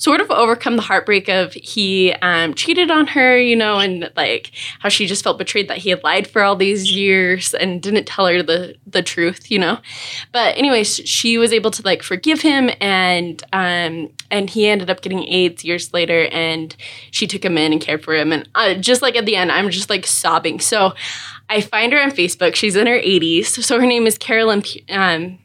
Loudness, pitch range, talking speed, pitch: -15 LUFS, 175-220 Hz, 215 wpm, 195 Hz